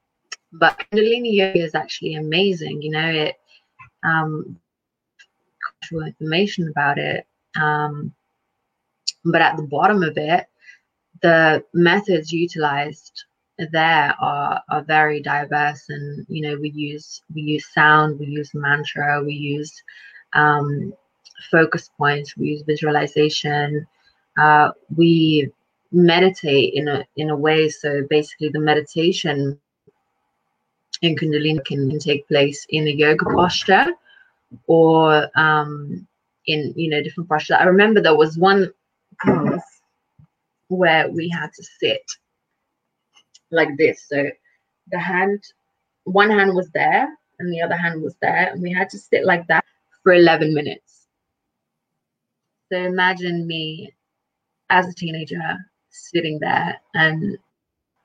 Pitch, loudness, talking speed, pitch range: 155 Hz, -18 LUFS, 125 wpm, 150-180 Hz